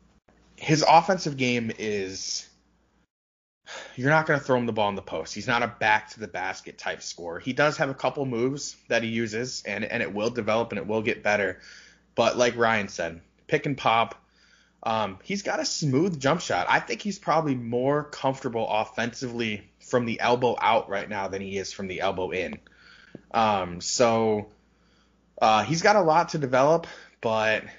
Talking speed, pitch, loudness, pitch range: 190 wpm, 120 Hz, -25 LUFS, 110-140 Hz